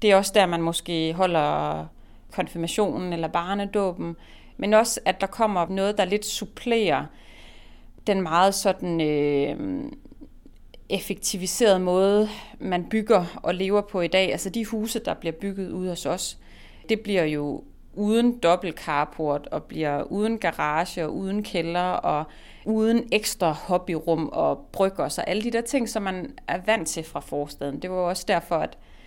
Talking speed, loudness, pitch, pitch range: 165 wpm, -25 LUFS, 185 Hz, 165-210 Hz